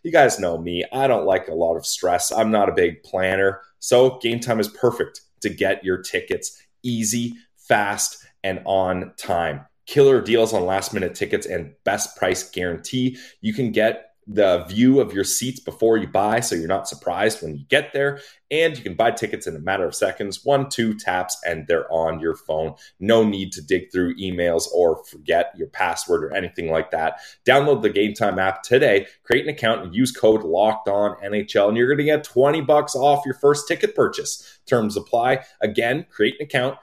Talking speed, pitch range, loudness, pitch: 200 wpm, 95-150 Hz, -21 LUFS, 120 Hz